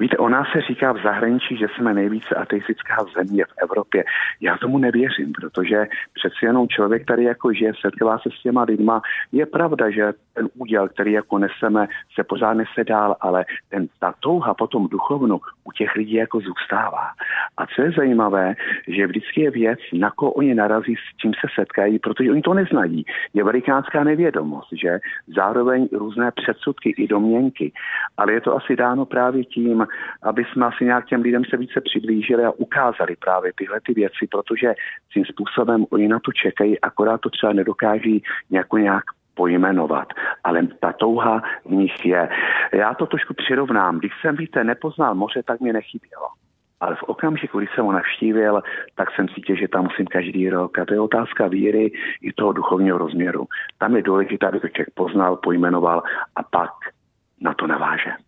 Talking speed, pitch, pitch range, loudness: 175 wpm, 110 Hz, 100-125 Hz, -20 LUFS